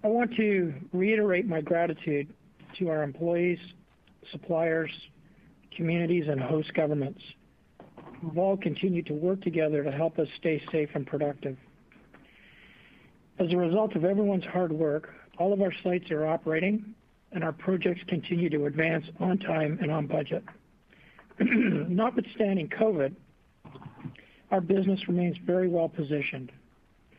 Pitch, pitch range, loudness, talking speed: 170 Hz, 155-190 Hz, -29 LUFS, 130 wpm